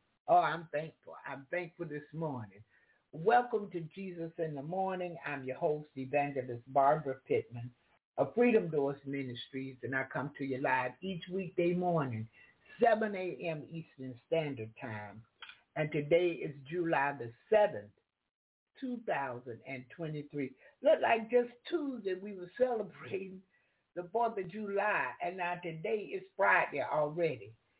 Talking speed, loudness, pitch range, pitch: 135 wpm, -34 LUFS, 135-190 Hz, 165 Hz